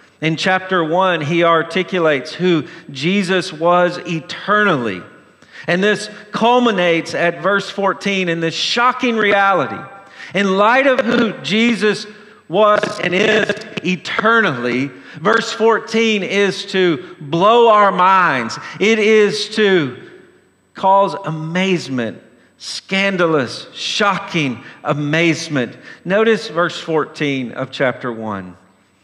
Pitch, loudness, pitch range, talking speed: 185 Hz, -16 LUFS, 160-210 Hz, 100 wpm